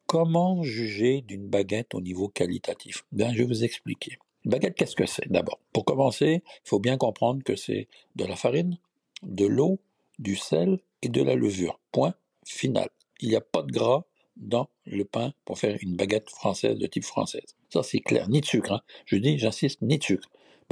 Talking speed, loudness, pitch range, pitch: 200 wpm, -27 LUFS, 100-155 Hz, 120 Hz